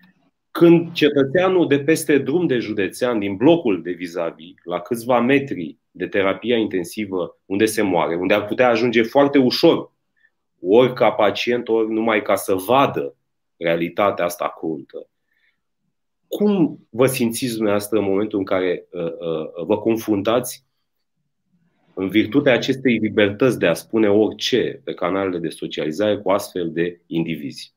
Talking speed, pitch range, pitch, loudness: 140 wpm, 100-140 Hz, 115 Hz, -19 LUFS